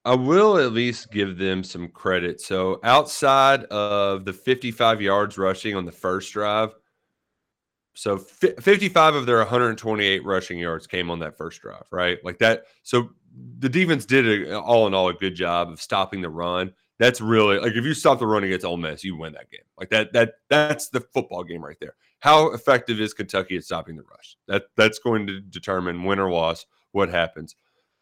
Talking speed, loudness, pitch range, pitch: 195 wpm, -21 LUFS, 90-120 Hz, 100 Hz